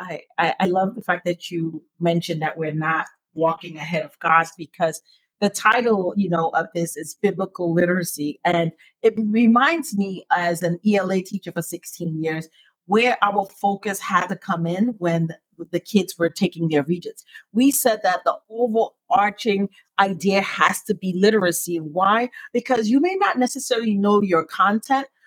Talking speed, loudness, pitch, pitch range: 165 wpm, -21 LUFS, 185 Hz, 170-210 Hz